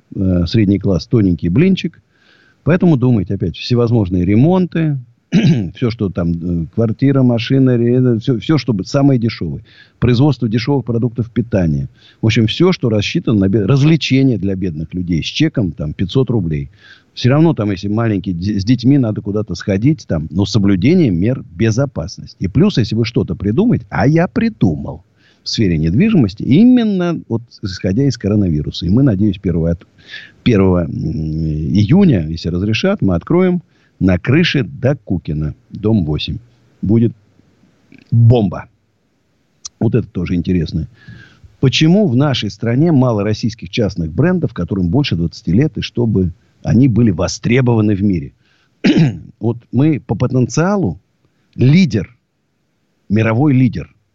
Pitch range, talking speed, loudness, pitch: 95-135 Hz, 135 wpm, -15 LUFS, 115 Hz